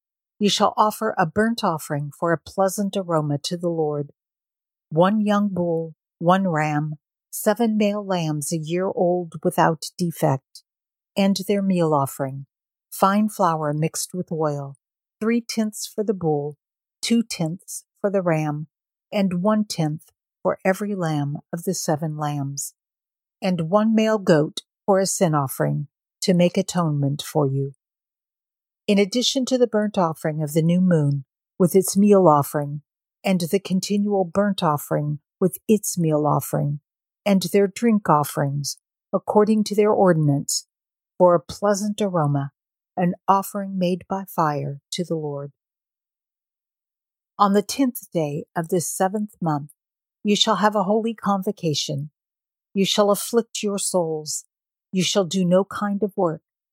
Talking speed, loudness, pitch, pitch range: 145 wpm, -22 LUFS, 180 Hz, 155-205 Hz